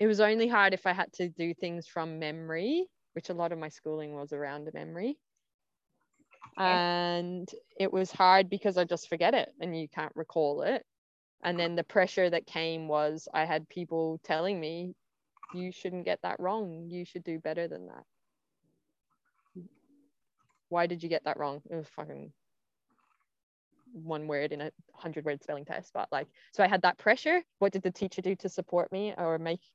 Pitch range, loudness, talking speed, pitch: 160-190 Hz, -31 LUFS, 190 wpm, 175 Hz